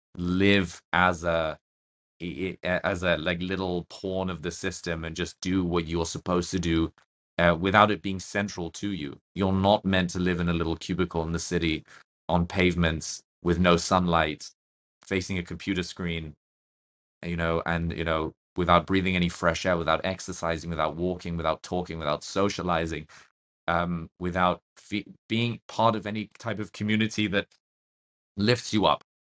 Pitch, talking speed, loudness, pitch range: 90 Hz, 160 wpm, -27 LUFS, 80-95 Hz